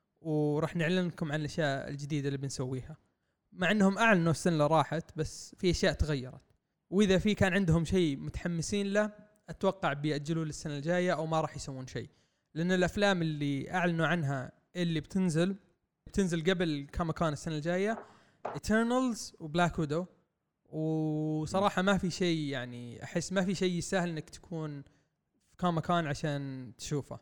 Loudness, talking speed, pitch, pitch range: -32 LUFS, 140 wpm, 165 Hz, 150-185 Hz